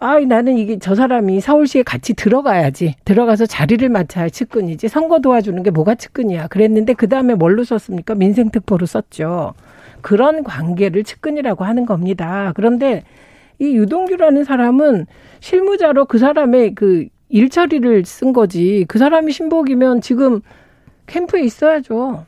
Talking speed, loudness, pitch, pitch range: 345 characters per minute, -14 LUFS, 230 Hz, 195-270 Hz